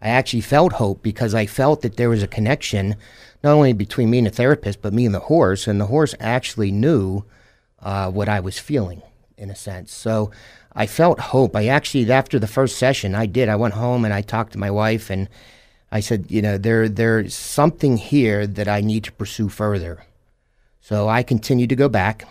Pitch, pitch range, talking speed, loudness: 110 Hz, 105-125 Hz, 215 wpm, -19 LUFS